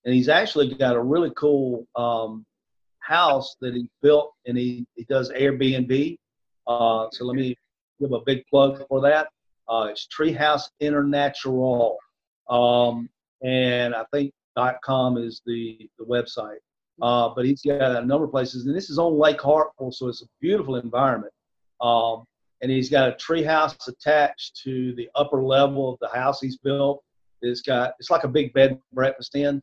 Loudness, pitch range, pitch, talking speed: -23 LUFS, 120-140 Hz, 130 Hz, 170 wpm